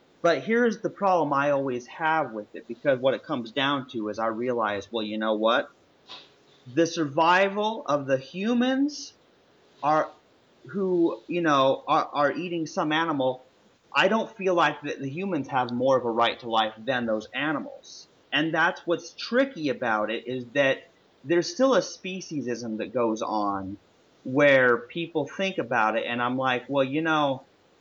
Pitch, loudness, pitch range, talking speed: 140 Hz, -26 LUFS, 120-170 Hz, 170 wpm